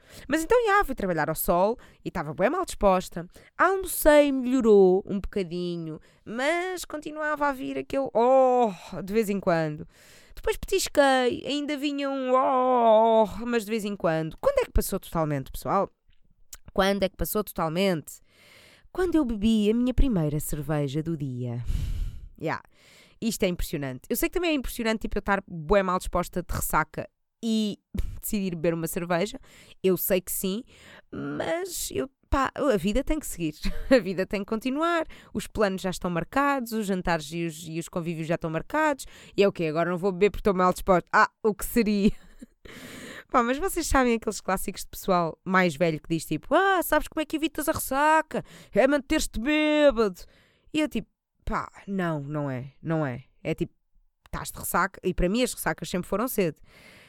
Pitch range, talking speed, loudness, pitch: 175-265 Hz, 185 wpm, -26 LUFS, 205 Hz